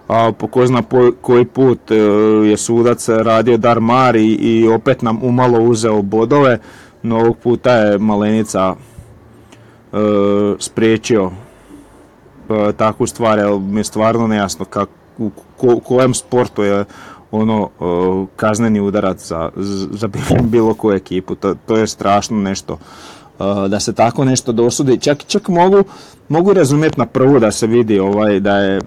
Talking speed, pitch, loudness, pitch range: 150 wpm, 110 Hz, -14 LUFS, 100-120 Hz